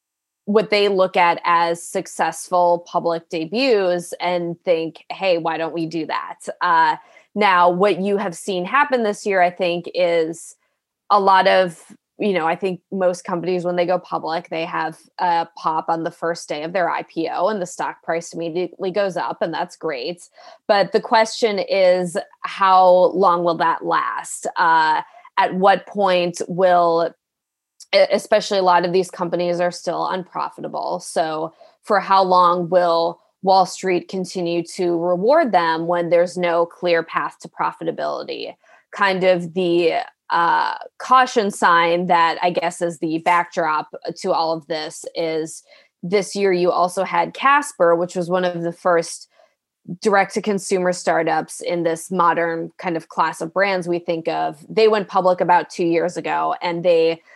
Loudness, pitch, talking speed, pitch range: -19 LUFS, 180 Hz, 165 wpm, 170-200 Hz